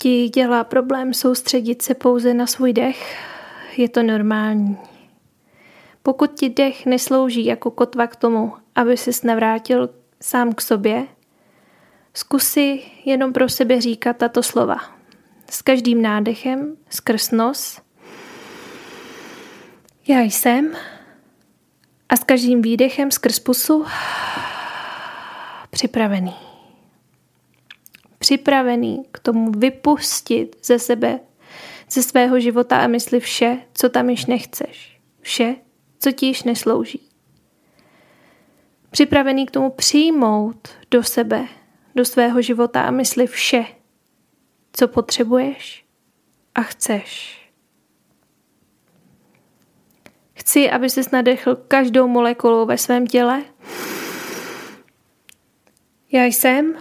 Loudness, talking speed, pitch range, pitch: -18 LUFS, 100 wpm, 240-270 Hz, 250 Hz